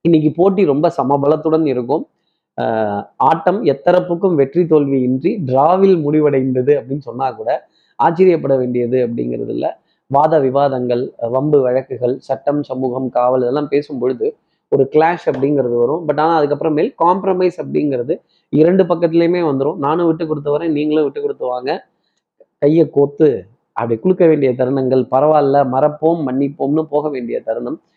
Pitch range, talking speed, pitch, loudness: 130-165 Hz, 130 wpm, 145 Hz, -15 LUFS